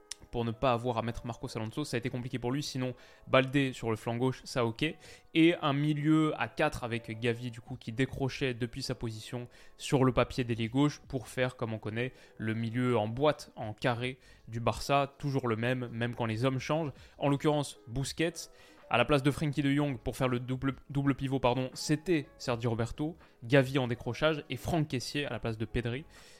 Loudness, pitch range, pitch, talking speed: -32 LUFS, 120-140 Hz, 130 Hz, 210 wpm